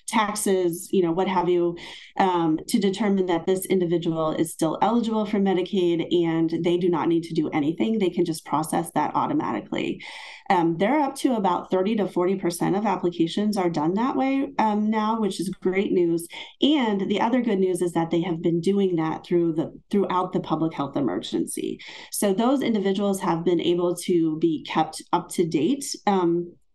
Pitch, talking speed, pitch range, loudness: 185 Hz, 185 wpm, 170-210 Hz, -24 LUFS